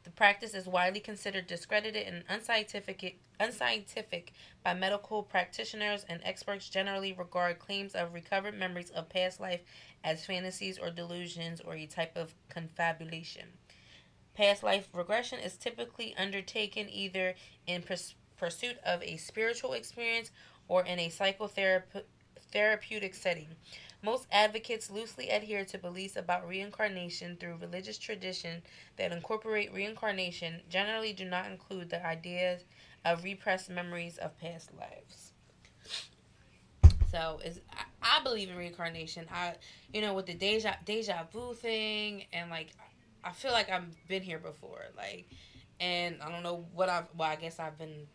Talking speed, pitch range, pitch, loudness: 140 wpm, 170-205 Hz, 185 Hz, -35 LUFS